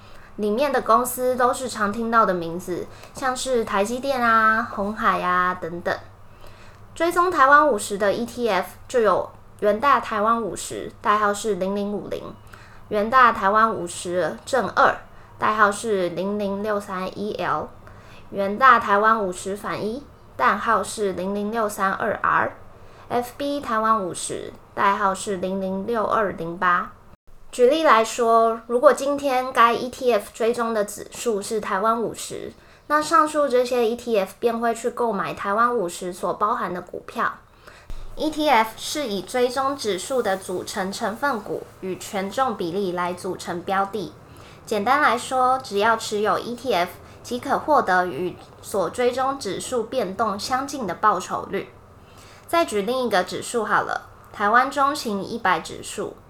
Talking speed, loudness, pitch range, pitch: 225 characters per minute, -22 LUFS, 195-250 Hz, 220 Hz